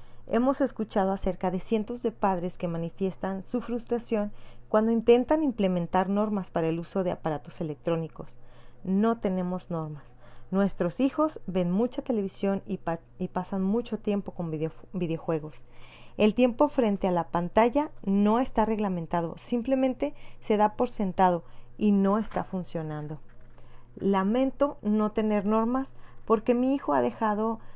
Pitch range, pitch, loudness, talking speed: 170-225 Hz, 195 Hz, -28 LUFS, 140 wpm